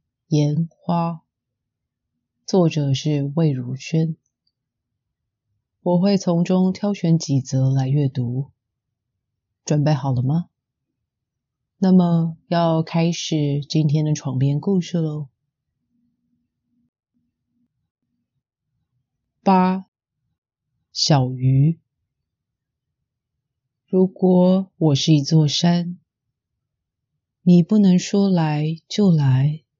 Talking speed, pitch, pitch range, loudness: 110 characters per minute, 150 Hz, 130-175 Hz, -19 LUFS